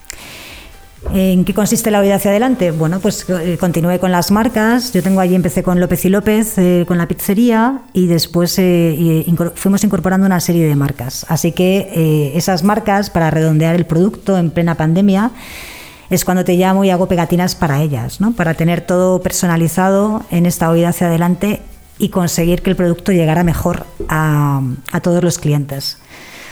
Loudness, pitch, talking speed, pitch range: -14 LUFS, 180 Hz, 175 wpm, 170-195 Hz